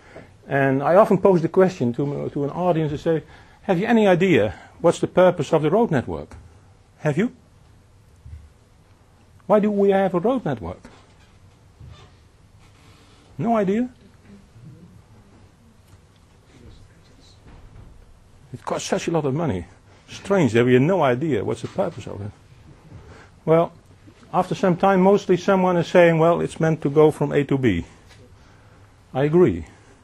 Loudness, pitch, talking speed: -20 LUFS, 120 Hz, 140 wpm